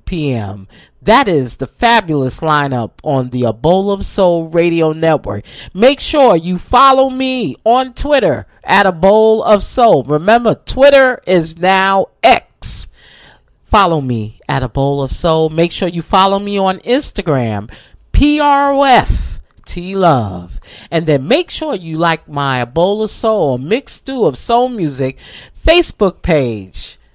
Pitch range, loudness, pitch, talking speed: 135-225 Hz, -12 LUFS, 175 Hz, 145 wpm